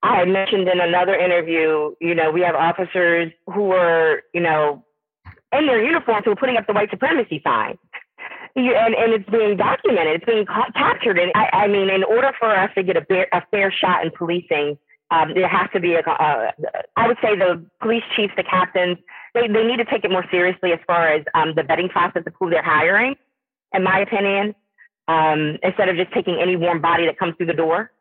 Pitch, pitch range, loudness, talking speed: 185 Hz, 170-205 Hz, -18 LUFS, 215 wpm